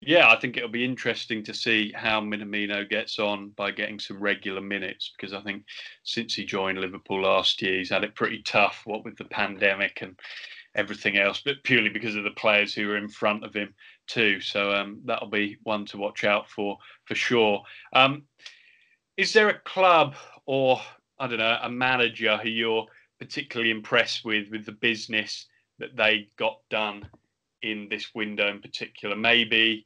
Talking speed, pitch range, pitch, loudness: 185 wpm, 105-120 Hz, 110 Hz, -25 LUFS